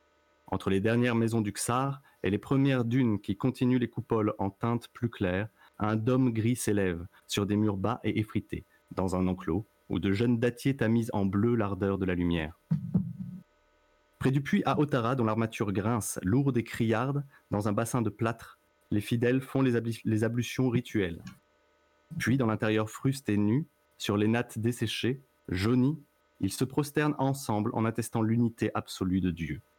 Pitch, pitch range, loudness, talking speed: 115 Hz, 100-125 Hz, -30 LUFS, 175 wpm